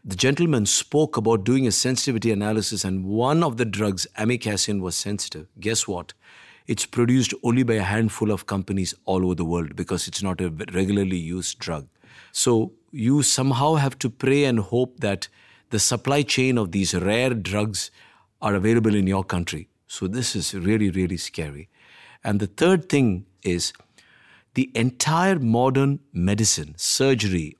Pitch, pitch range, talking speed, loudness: 110 Hz, 95-125 Hz, 160 wpm, -22 LUFS